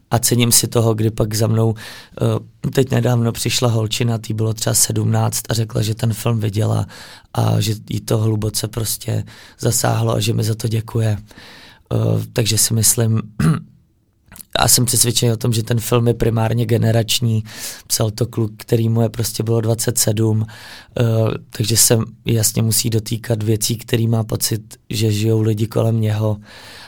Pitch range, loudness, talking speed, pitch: 110-120 Hz, -17 LUFS, 160 wpm, 115 Hz